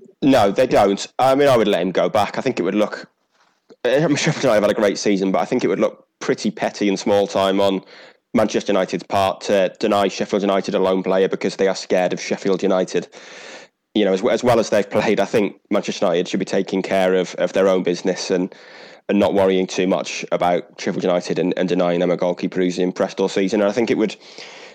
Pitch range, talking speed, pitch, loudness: 95-100 Hz, 240 wpm, 95 Hz, -19 LUFS